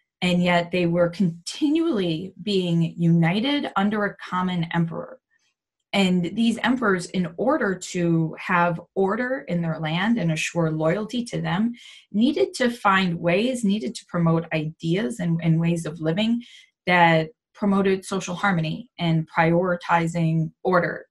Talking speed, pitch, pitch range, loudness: 135 wpm, 180 Hz, 170-205 Hz, -23 LUFS